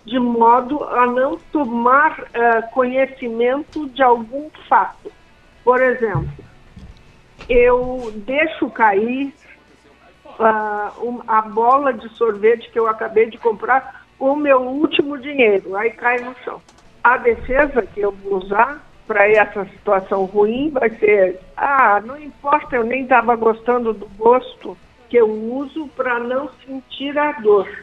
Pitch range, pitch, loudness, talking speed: 225-270 Hz, 245 Hz, -17 LUFS, 140 wpm